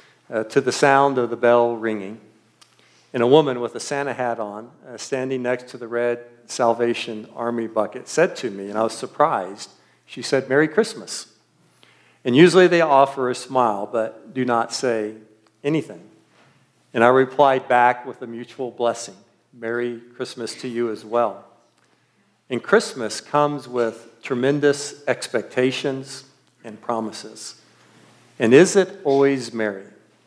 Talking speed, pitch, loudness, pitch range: 145 wpm, 120 Hz, -21 LUFS, 115-135 Hz